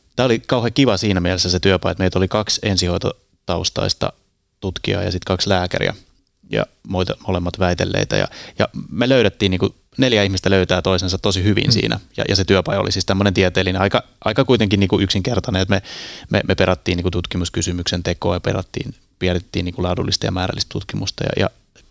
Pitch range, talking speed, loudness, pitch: 90-105 Hz, 180 wpm, -19 LUFS, 95 Hz